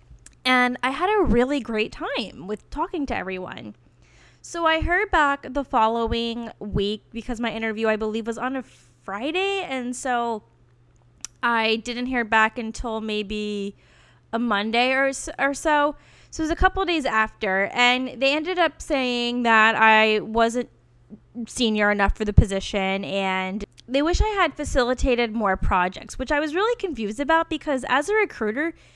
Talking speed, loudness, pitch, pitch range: 165 wpm, -23 LUFS, 240 Hz, 215-285 Hz